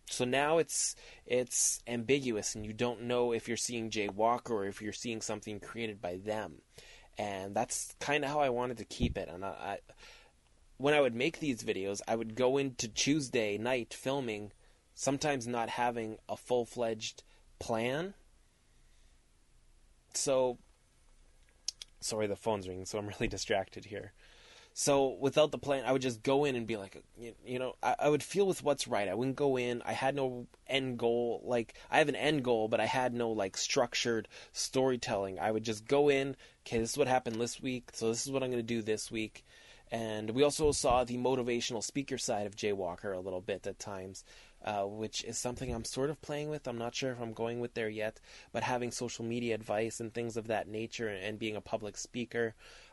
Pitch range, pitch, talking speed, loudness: 110-130 Hz, 115 Hz, 200 wpm, -34 LUFS